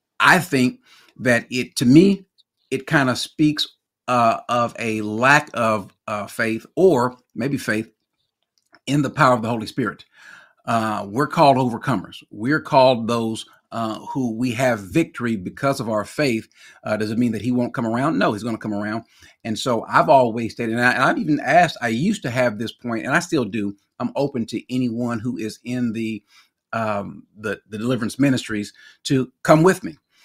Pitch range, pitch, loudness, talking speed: 110-135 Hz, 120 Hz, -20 LUFS, 190 wpm